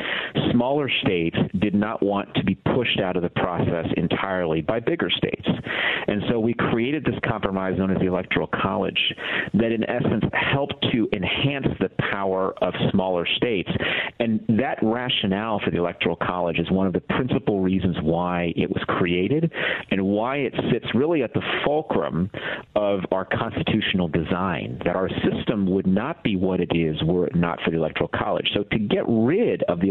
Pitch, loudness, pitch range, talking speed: 95 Hz, -23 LUFS, 90-105 Hz, 180 wpm